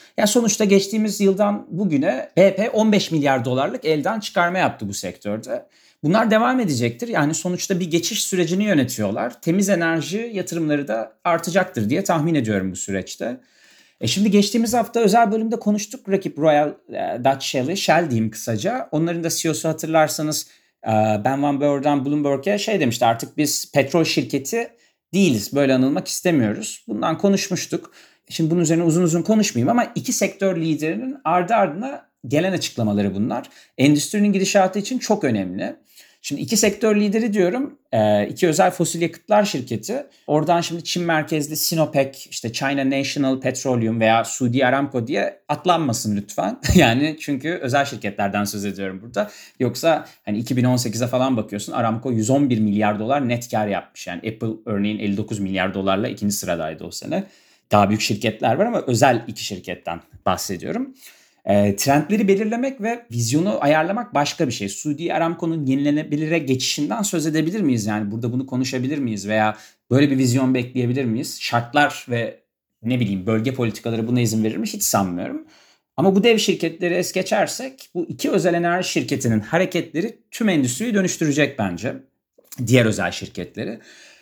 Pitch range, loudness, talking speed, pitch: 120-190 Hz, -20 LUFS, 150 wpm, 150 Hz